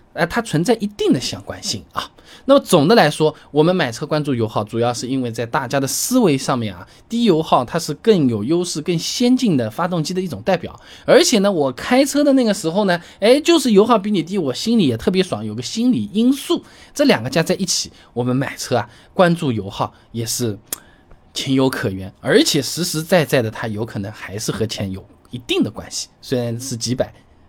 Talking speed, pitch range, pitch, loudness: 310 characters per minute, 120-200 Hz, 155 Hz, -18 LUFS